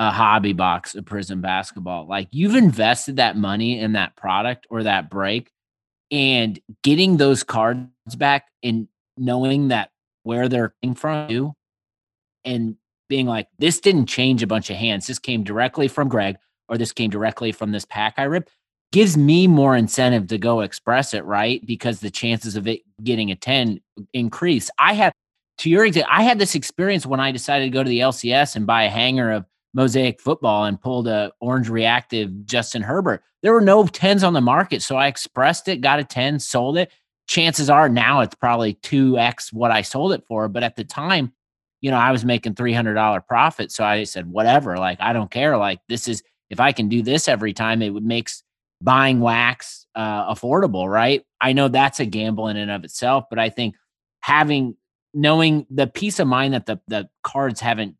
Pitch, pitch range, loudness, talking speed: 120 Hz, 110-135 Hz, -19 LUFS, 200 wpm